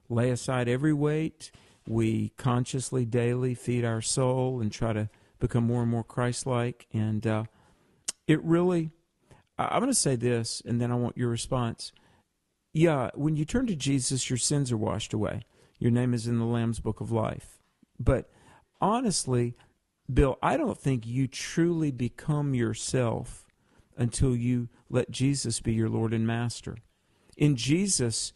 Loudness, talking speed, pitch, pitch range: -28 LUFS, 160 wpm, 120 Hz, 115-135 Hz